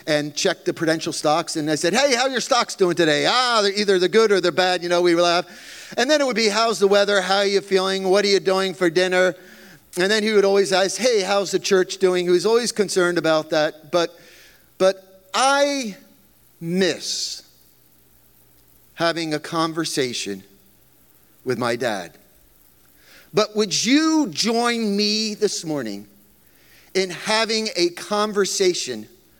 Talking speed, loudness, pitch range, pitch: 170 wpm, -20 LUFS, 165-210 Hz, 190 Hz